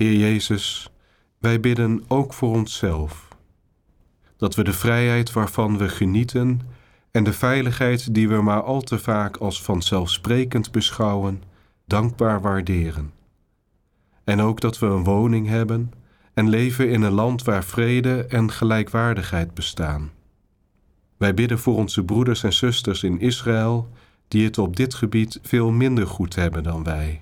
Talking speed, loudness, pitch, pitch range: 145 wpm, -21 LUFS, 110 Hz, 95-115 Hz